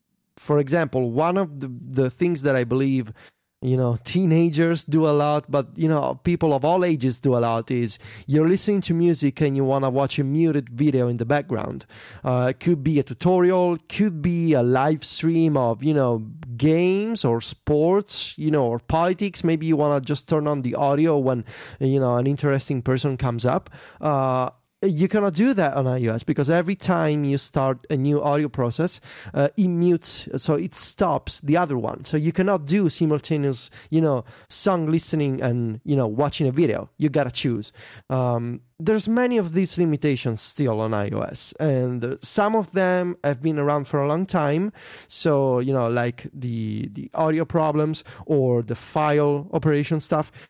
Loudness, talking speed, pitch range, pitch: -22 LUFS, 185 wpm, 130-165 Hz, 145 Hz